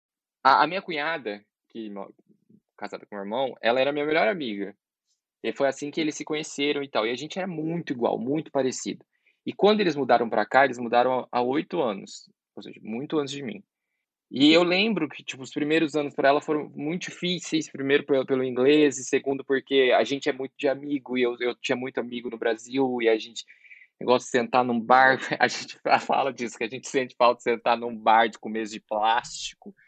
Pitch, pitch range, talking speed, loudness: 135 Hz, 120-150 Hz, 215 wpm, -25 LUFS